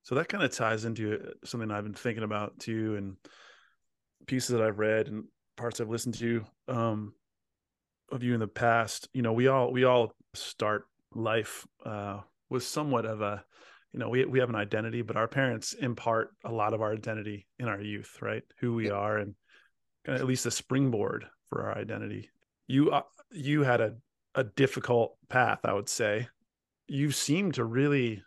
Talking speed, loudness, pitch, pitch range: 185 wpm, -31 LUFS, 115 Hz, 105-130 Hz